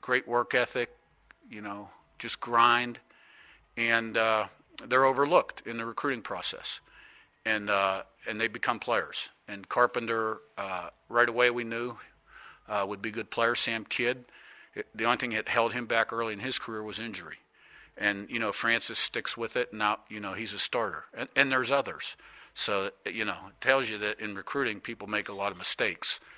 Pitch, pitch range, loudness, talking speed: 115 Hz, 105-120 Hz, -29 LUFS, 185 wpm